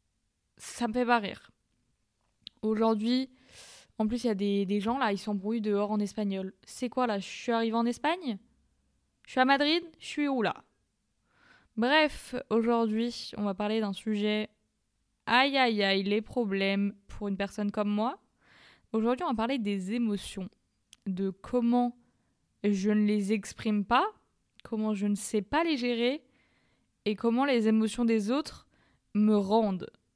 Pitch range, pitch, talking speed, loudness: 205-245 Hz, 220 Hz, 160 wpm, -29 LUFS